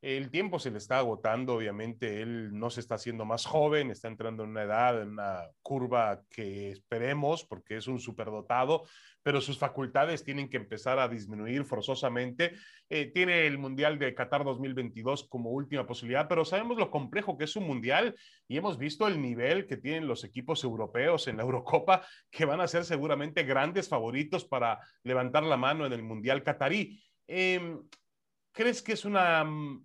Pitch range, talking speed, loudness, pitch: 120-165 Hz, 175 wpm, -31 LUFS, 135 Hz